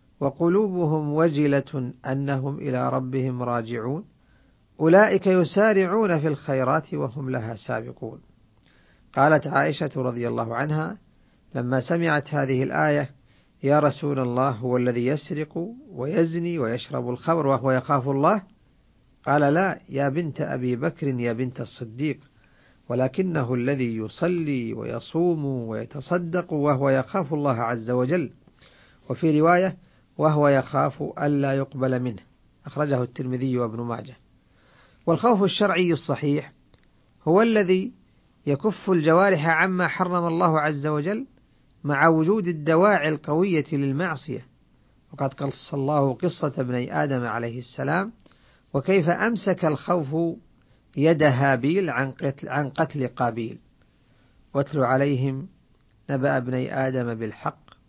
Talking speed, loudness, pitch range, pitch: 105 wpm, -24 LUFS, 130-165 Hz, 140 Hz